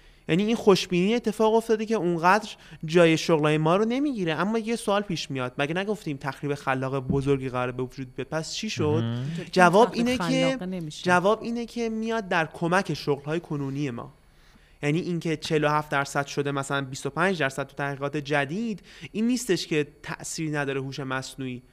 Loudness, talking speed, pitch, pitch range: -26 LUFS, 165 wpm, 160 Hz, 140-195 Hz